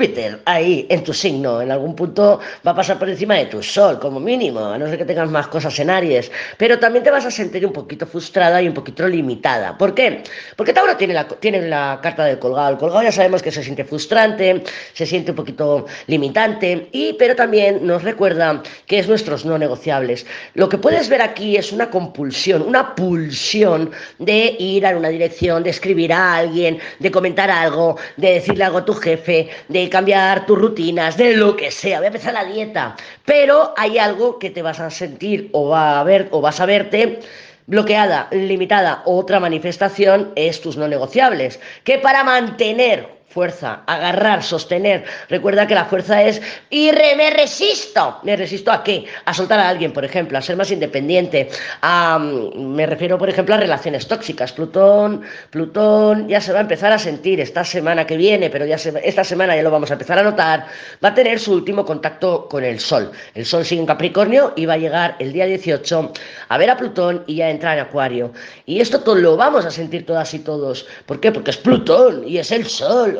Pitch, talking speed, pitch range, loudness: 180 Hz, 205 wpm, 160-205 Hz, -16 LUFS